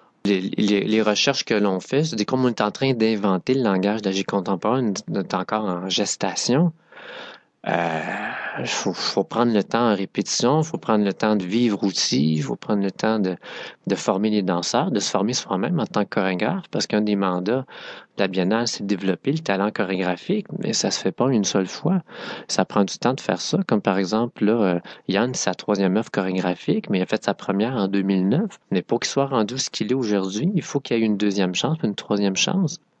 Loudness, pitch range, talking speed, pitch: -22 LUFS, 95-130 Hz, 220 wpm, 105 Hz